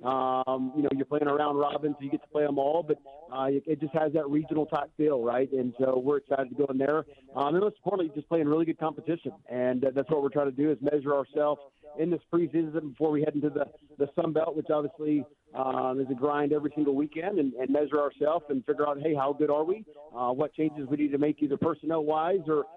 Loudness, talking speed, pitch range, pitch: -29 LUFS, 255 wpm, 140-155 Hz, 150 Hz